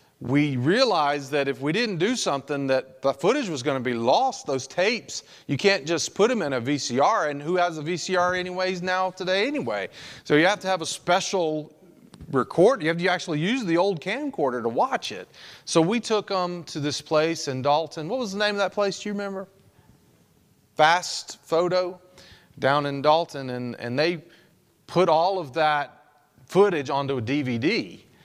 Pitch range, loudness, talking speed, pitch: 145-185 Hz, -24 LUFS, 190 wpm, 165 Hz